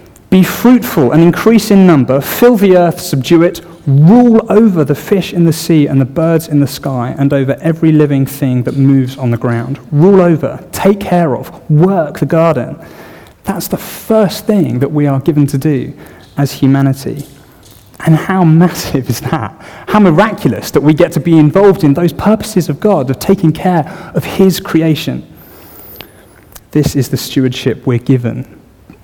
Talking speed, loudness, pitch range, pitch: 175 wpm, -10 LUFS, 135-180 Hz, 155 Hz